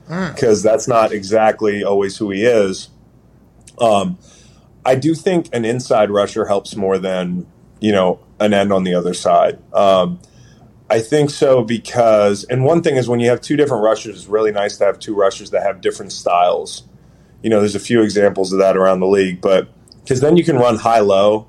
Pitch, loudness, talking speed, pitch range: 110 Hz, -15 LUFS, 200 wpm, 100-125 Hz